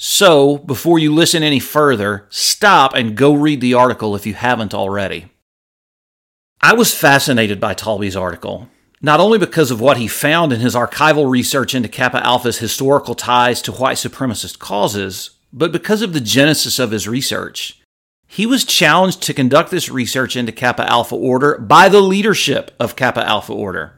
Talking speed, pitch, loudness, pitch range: 170 wpm, 130 Hz, -14 LUFS, 115-150 Hz